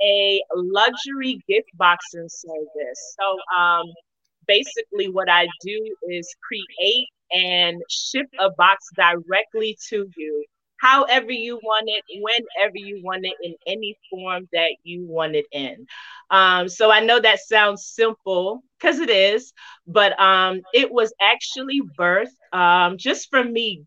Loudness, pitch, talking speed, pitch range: -19 LUFS, 195 Hz, 140 wpm, 175-230 Hz